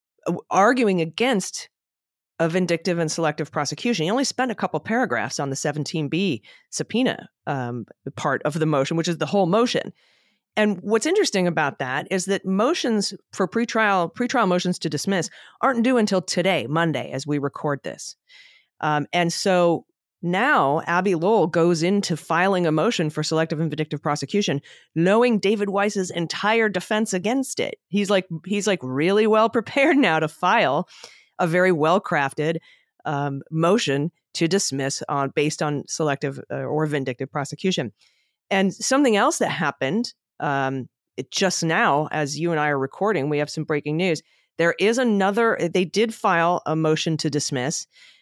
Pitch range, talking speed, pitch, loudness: 150-205 Hz, 160 wpm, 170 Hz, -22 LUFS